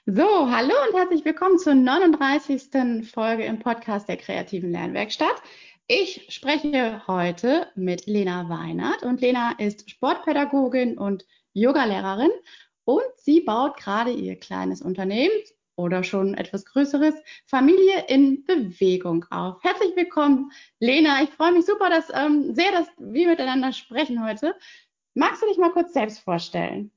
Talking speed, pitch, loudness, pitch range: 140 wpm, 270 Hz, -22 LUFS, 210-330 Hz